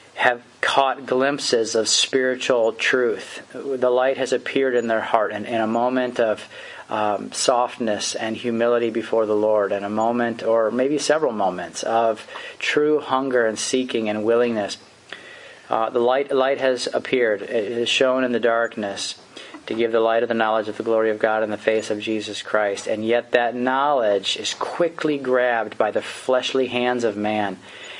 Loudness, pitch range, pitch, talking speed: -21 LUFS, 110-130 Hz, 115 Hz, 175 wpm